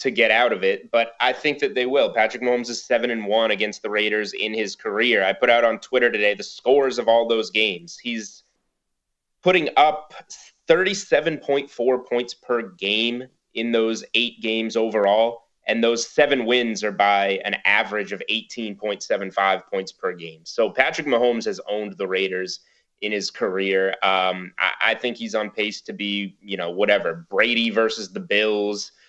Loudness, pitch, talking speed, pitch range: -21 LUFS, 110 Hz, 175 wpm, 100-120 Hz